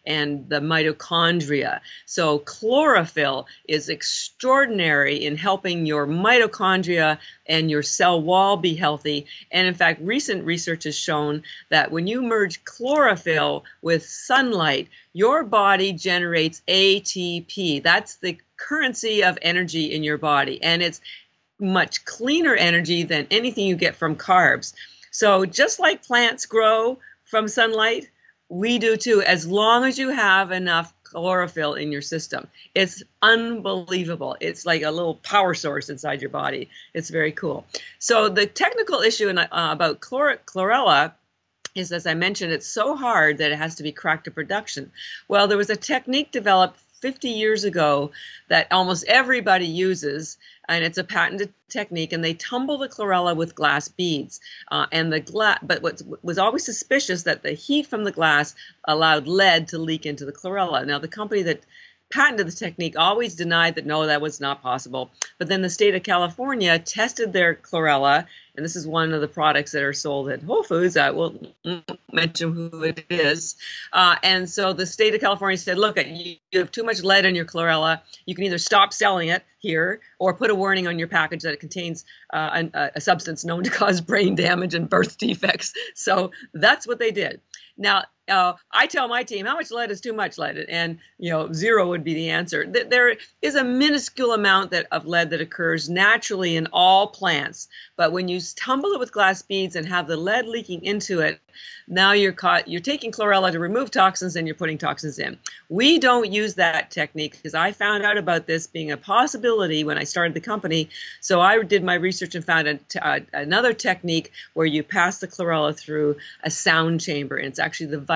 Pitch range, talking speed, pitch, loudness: 160-210 Hz, 185 wpm, 180 Hz, -21 LUFS